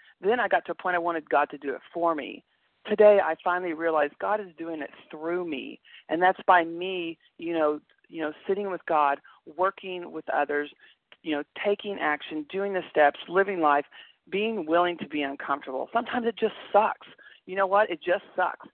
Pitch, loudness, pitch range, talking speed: 170 Hz, -27 LUFS, 150-195 Hz, 200 wpm